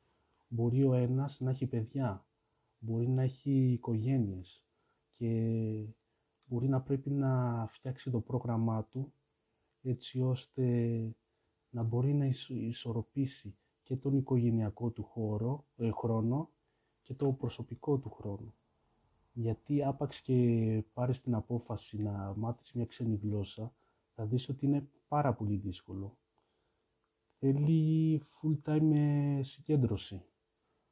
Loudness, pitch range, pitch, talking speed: -34 LUFS, 110-135 Hz, 120 Hz, 115 wpm